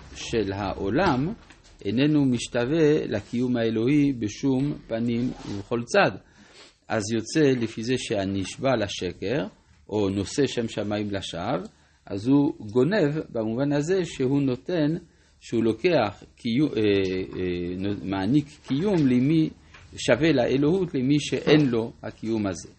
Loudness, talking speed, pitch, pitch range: -25 LUFS, 115 wpm, 120 Hz, 105-145 Hz